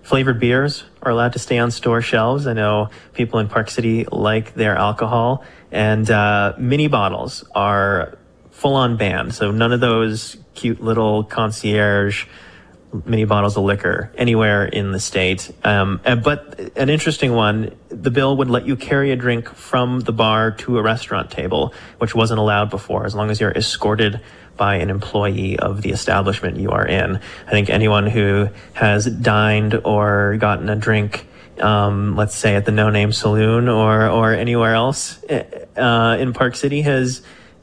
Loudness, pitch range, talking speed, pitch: -18 LUFS, 105-120 Hz, 170 wpm, 110 Hz